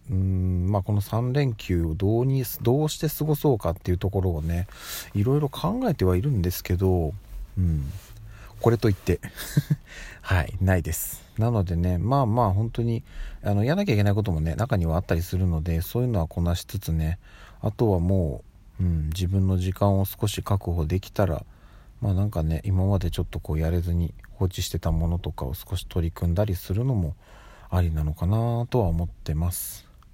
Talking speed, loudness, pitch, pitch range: 365 characters per minute, -26 LUFS, 95 Hz, 85-110 Hz